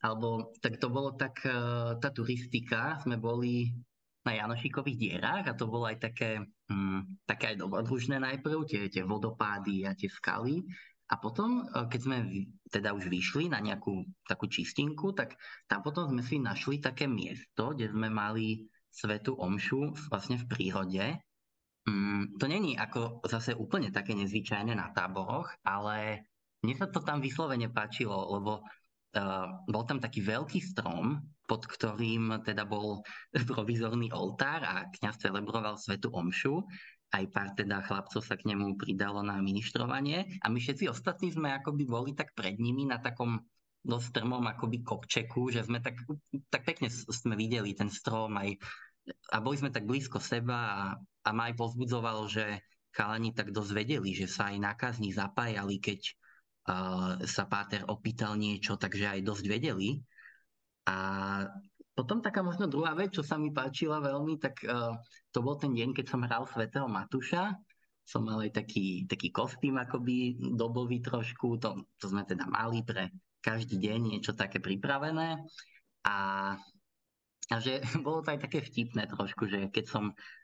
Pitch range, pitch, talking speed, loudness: 105-130 Hz, 115 Hz, 155 wpm, -35 LUFS